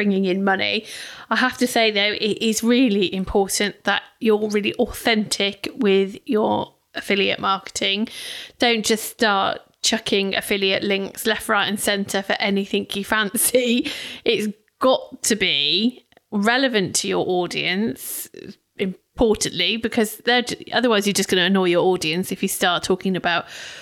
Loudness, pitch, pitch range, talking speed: -20 LUFS, 210 Hz, 195-230 Hz, 145 wpm